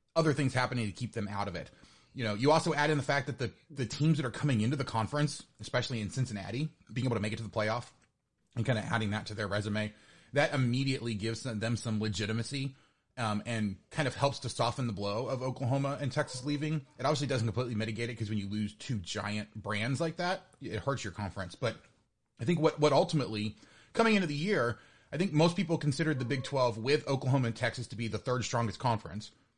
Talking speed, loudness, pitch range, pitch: 230 wpm, -33 LUFS, 110-145 Hz, 125 Hz